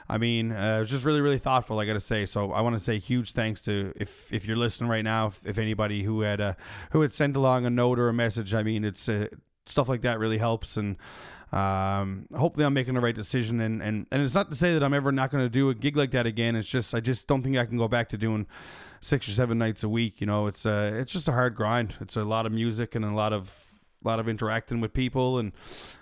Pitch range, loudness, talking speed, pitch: 105-125 Hz, -27 LUFS, 280 wpm, 115 Hz